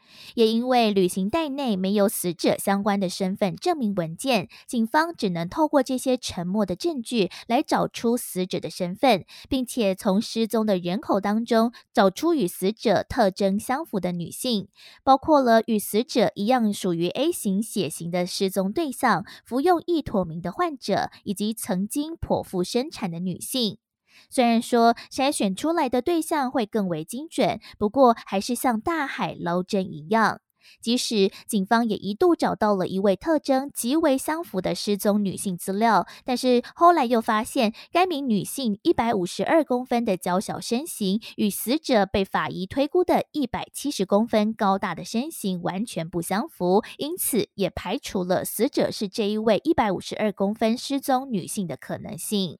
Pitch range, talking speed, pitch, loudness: 195-260 Hz, 260 characters per minute, 220 Hz, -24 LUFS